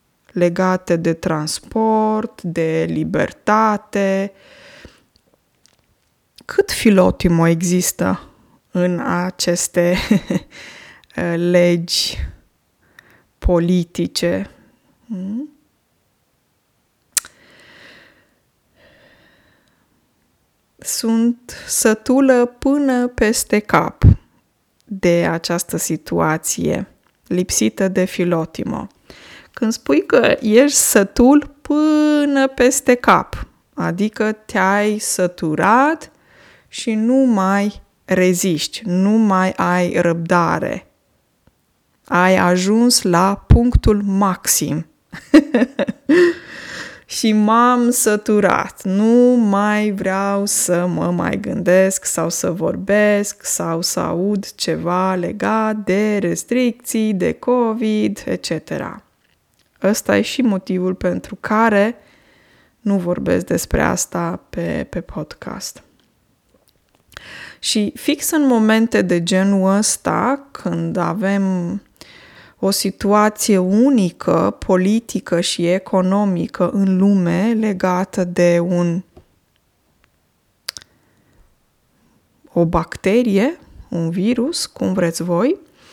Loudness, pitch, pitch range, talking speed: -17 LUFS, 200 Hz, 180-230 Hz, 75 wpm